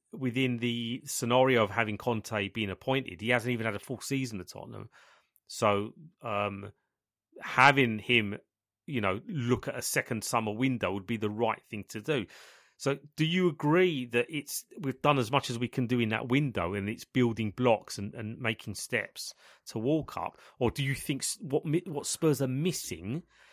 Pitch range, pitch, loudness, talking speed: 110-135 Hz, 125 Hz, -30 LUFS, 185 wpm